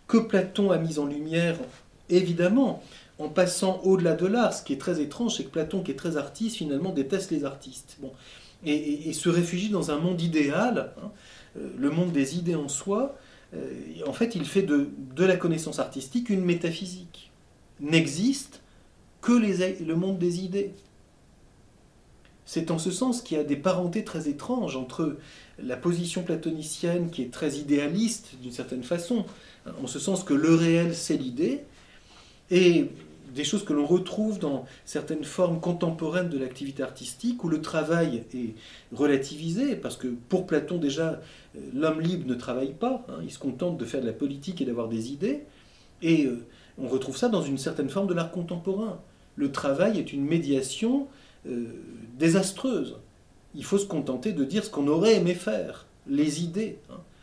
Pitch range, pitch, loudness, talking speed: 140-190 Hz, 165 Hz, -27 LUFS, 175 wpm